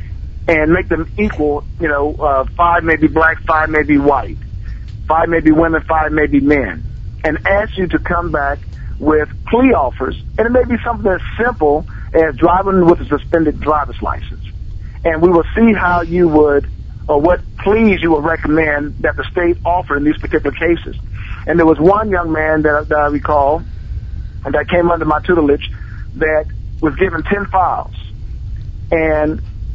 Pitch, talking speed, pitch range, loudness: 155 Hz, 180 wpm, 145-170 Hz, -14 LUFS